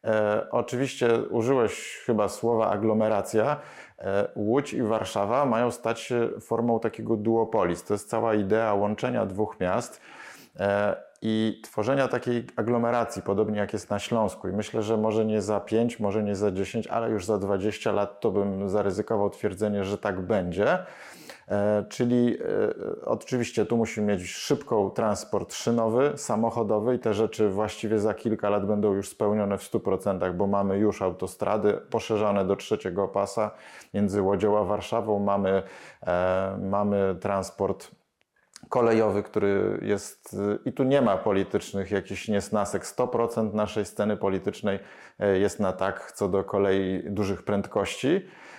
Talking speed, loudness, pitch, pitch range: 145 wpm, -27 LUFS, 105 Hz, 100-115 Hz